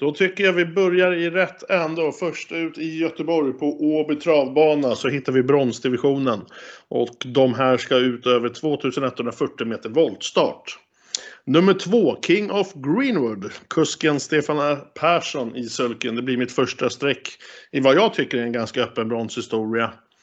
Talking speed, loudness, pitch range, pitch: 155 wpm, -21 LUFS, 125-160 Hz, 145 Hz